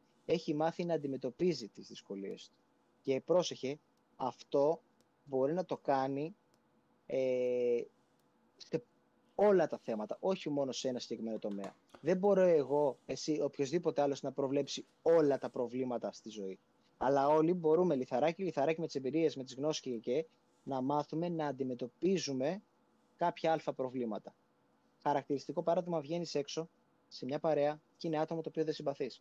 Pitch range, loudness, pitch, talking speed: 130-160 Hz, -35 LUFS, 145 Hz, 150 wpm